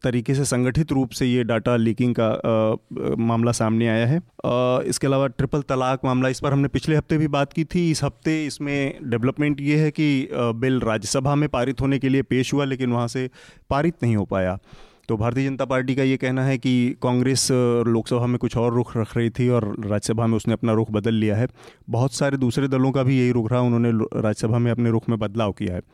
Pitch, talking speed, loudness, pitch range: 125 Hz, 230 wpm, -22 LUFS, 115-135 Hz